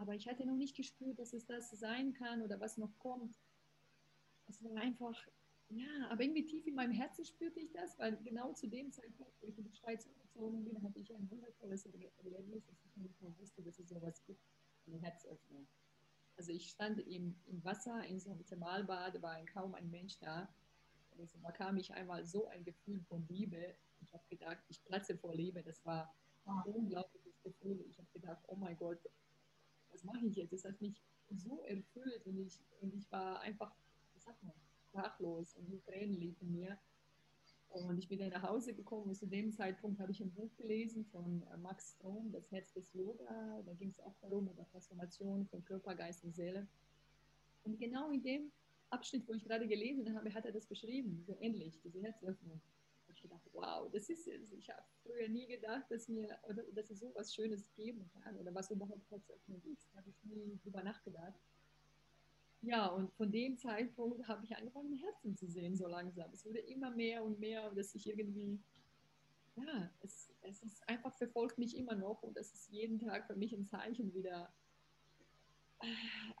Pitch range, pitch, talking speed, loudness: 180-225 Hz, 200 Hz, 190 wpm, -47 LUFS